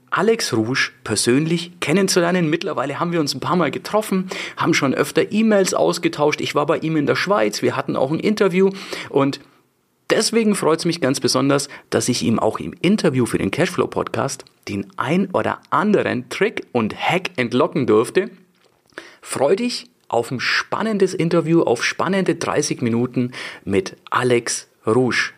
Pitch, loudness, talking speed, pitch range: 170 Hz, -19 LUFS, 160 wpm, 140-195 Hz